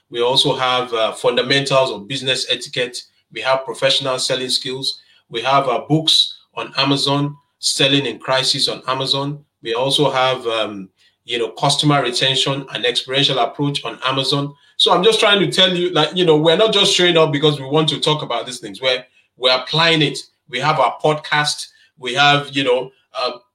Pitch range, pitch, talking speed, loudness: 130-155 Hz, 140 Hz, 190 wpm, -16 LUFS